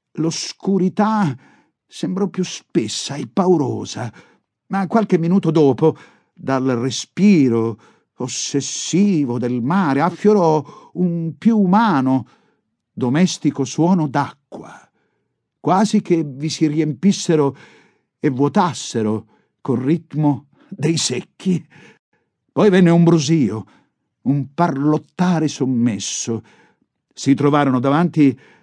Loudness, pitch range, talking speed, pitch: -18 LUFS, 135-180 Hz, 90 wpm, 155 Hz